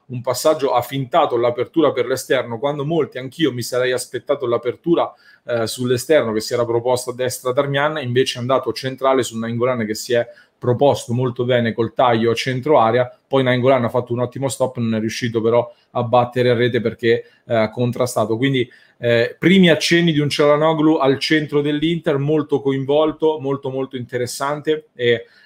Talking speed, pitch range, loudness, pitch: 175 wpm, 120-145 Hz, -18 LUFS, 125 Hz